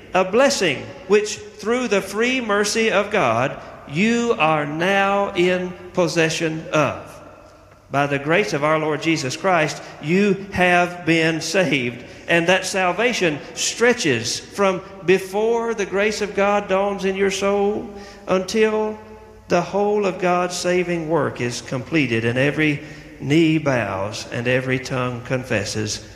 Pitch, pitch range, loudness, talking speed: 180 Hz, 145-200 Hz, -20 LUFS, 135 wpm